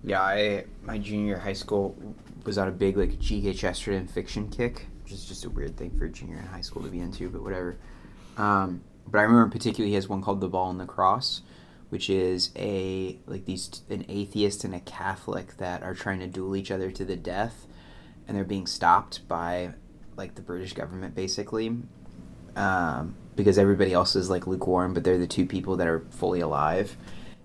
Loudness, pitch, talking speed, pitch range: -28 LUFS, 95 Hz, 200 wpm, 90-100 Hz